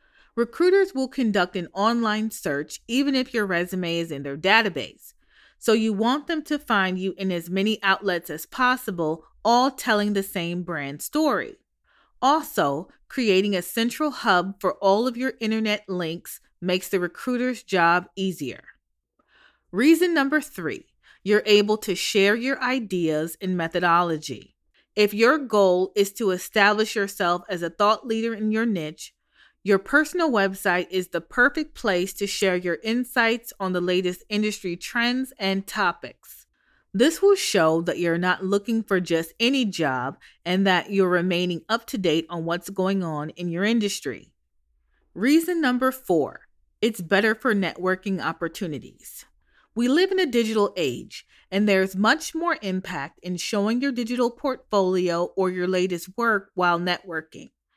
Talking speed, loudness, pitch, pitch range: 155 wpm, -23 LUFS, 195 Hz, 180-235 Hz